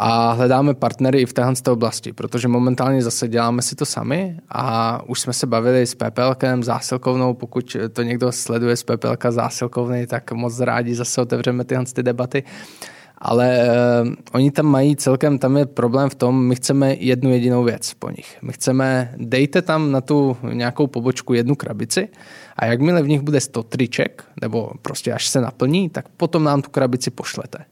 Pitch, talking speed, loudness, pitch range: 125 Hz, 175 wpm, -19 LUFS, 120-135 Hz